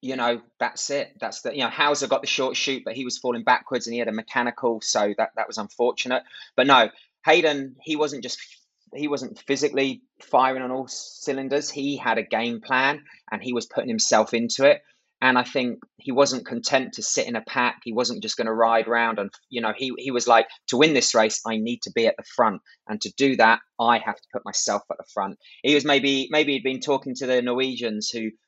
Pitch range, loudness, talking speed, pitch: 115-140 Hz, -23 LUFS, 235 wpm, 130 Hz